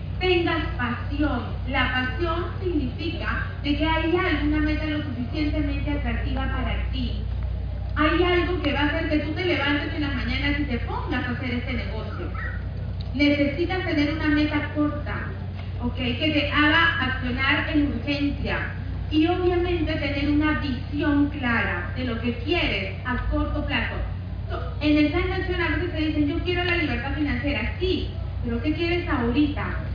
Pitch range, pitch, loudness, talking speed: 95-125 Hz, 100 Hz, -24 LUFS, 155 wpm